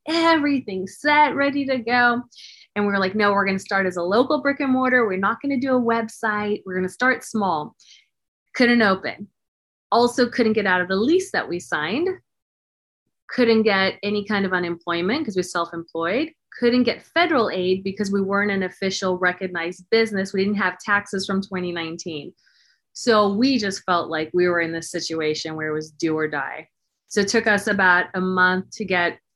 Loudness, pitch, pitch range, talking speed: -21 LUFS, 200 Hz, 180-240 Hz, 190 wpm